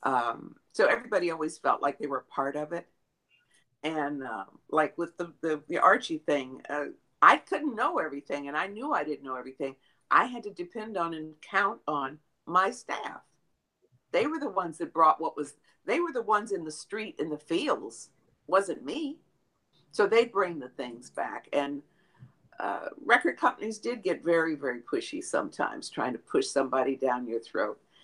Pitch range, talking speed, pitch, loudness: 145-215 Hz, 185 wpm, 165 Hz, -29 LUFS